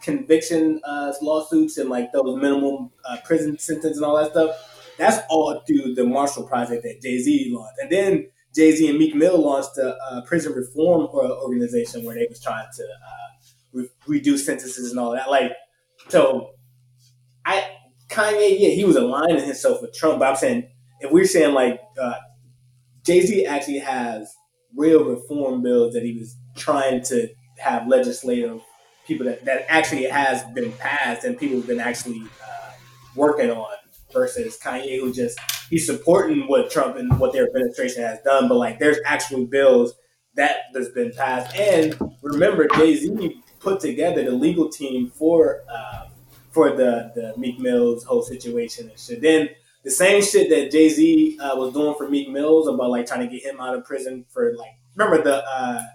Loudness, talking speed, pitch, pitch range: -20 LUFS, 180 wpm, 150 Hz, 125-205 Hz